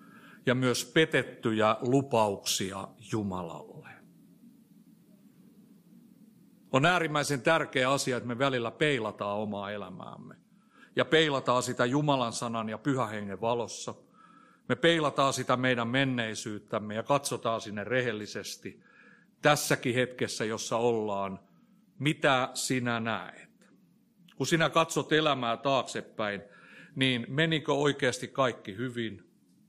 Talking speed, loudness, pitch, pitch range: 100 wpm, -29 LUFS, 130 Hz, 115-155 Hz